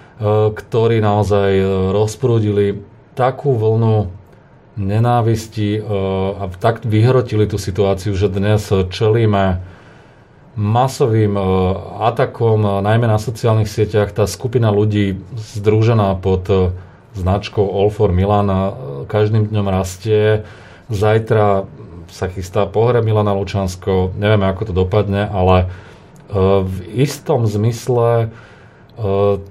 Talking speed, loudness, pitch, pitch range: 95 wpm, -16 LUFS, 105 Hz, 100-110 Hz